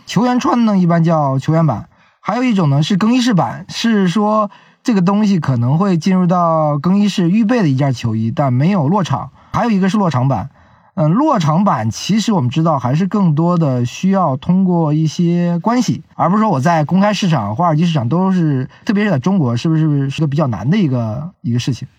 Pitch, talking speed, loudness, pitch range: 170 Hz, 320 characters per minute, -15 LUFS, 145-200 Hz